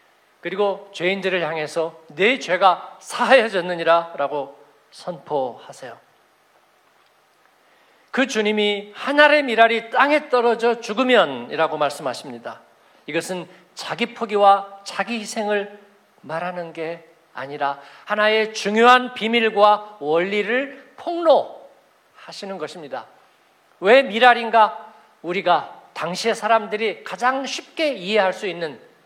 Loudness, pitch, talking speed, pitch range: -19 LUFS, 205 Hz, 250 characters per minute, 175-235 Hz